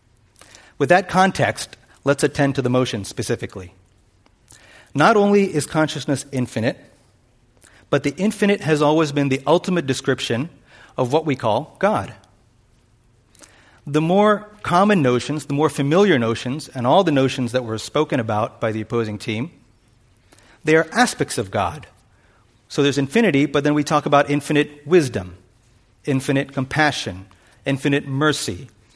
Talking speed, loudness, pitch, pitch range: 140 wpm, -19 LUFS, 130 Hz, 115-150 Hz